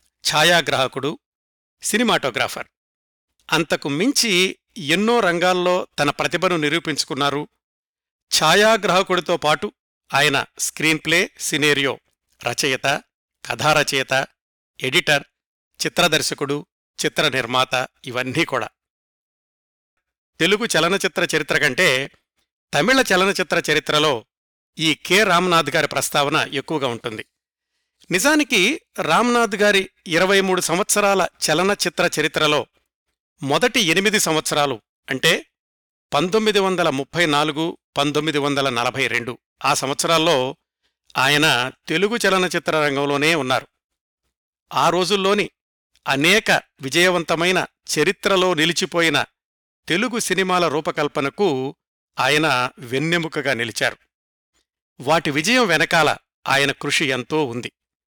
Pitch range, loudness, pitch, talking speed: 145-185 Hz, -19 LUFS, 160 Hz, 85 wpm